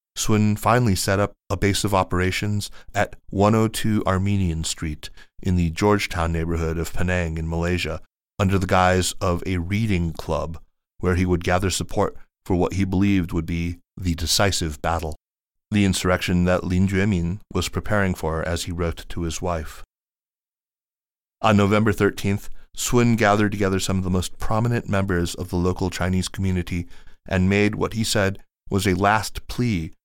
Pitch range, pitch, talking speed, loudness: 85-100 Hz, 90 Hz, 160 wpm, -22 LUFS